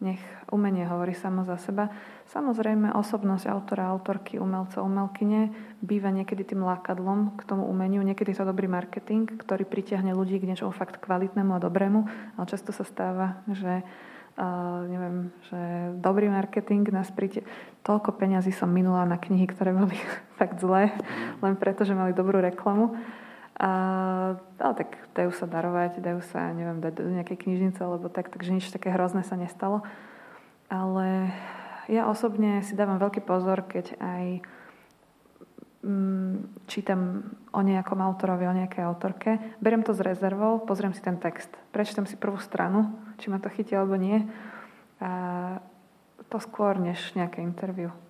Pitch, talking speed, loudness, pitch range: 195 Hz, 150 wpm, -28 LUFS, 185-210 Hz